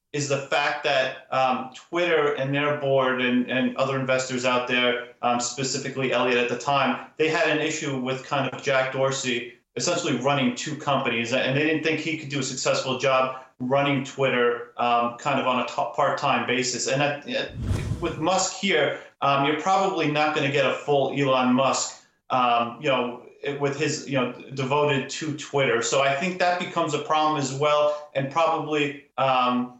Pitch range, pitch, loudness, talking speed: 125-150 Hz, 135 Hz, -24 LUFS, 185 wpm